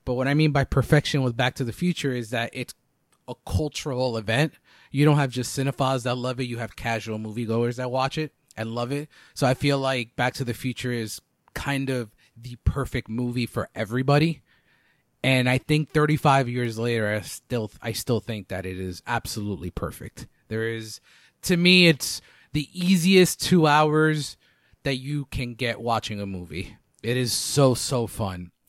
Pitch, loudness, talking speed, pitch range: 125 Hz, -24 LUFS, 185 wpm, 115-140 Hz